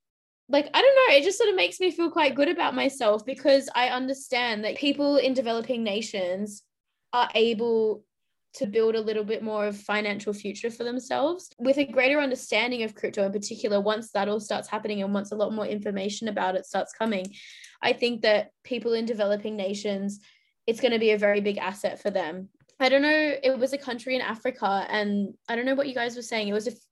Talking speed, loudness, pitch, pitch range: 220 wpm, -26 LUFS, 230 Hz, 210-265 Hz